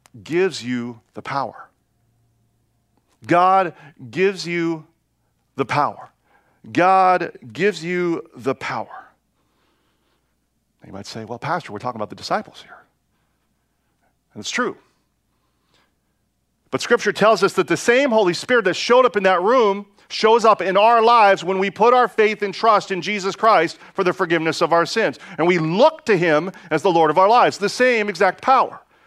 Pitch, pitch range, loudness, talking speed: 185 Hz, 155-205 Hz, -18 LUFS, 165 wpm